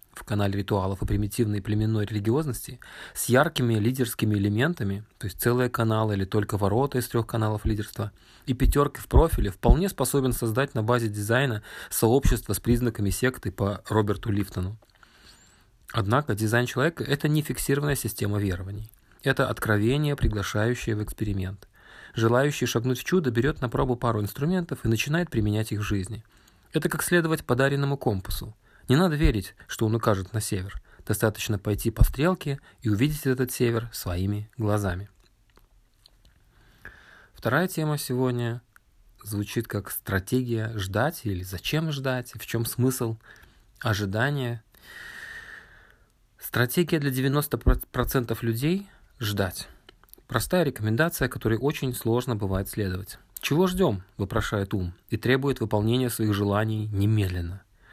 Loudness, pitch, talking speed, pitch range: -26 LUFS, 115 Hz, 130 wpm, 105-130 Hz